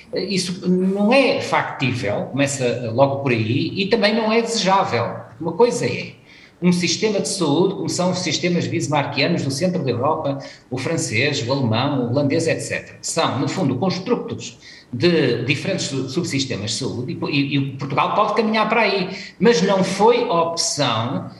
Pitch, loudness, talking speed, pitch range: 165 Hz, -19 LUFS, 155 wpm, 135-190 Hz